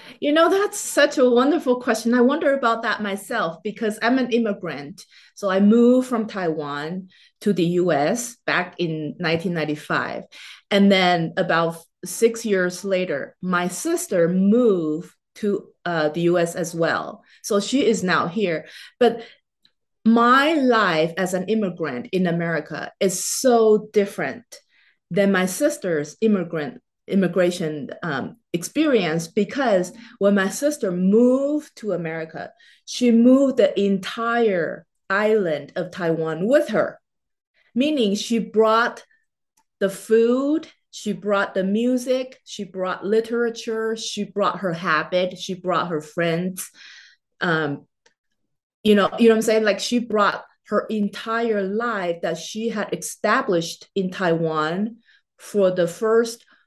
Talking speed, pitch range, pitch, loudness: 130 wpm, 175-230 Hz, 200 Hz, -21 LUFS